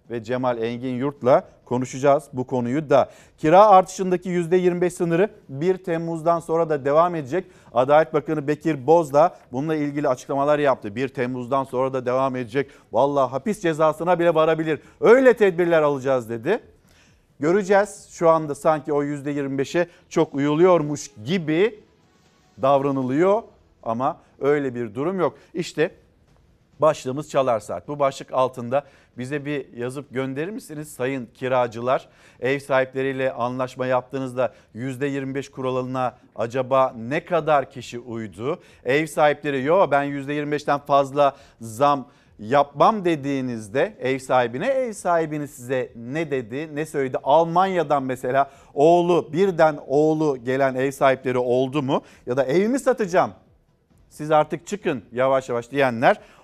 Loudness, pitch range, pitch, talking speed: -22 LUFS, 130-160 Hz, 140 Hz, 130 wpm